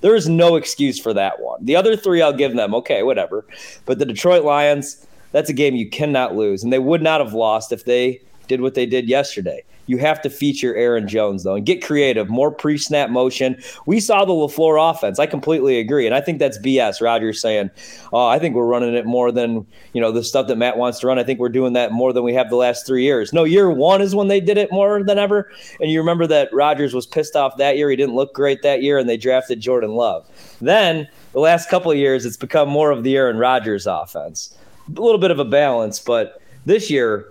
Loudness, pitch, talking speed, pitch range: -17 LUFS, 140 Hz, 245 wpm, 125-165 Hz